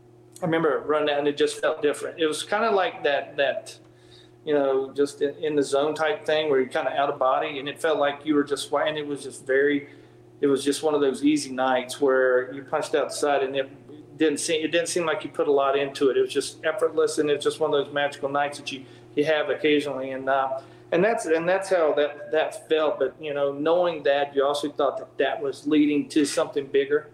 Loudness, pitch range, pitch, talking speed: -24 LUFS, 140-155 Hz, 145 Hz, 250 wpm